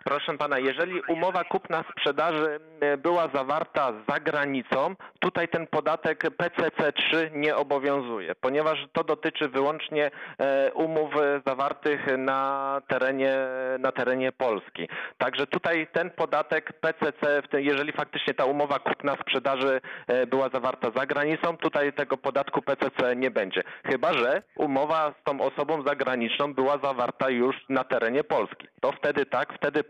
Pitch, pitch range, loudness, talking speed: 145 Hz, 135-155 Hz, -27 LUFS, 125 wpm